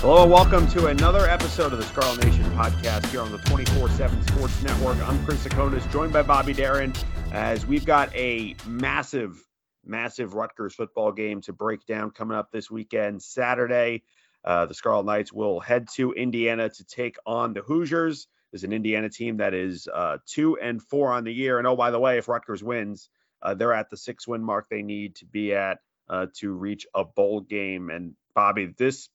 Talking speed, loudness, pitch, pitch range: 200 wpm, -24 LUFS, 110 Hz, 95-125 Hz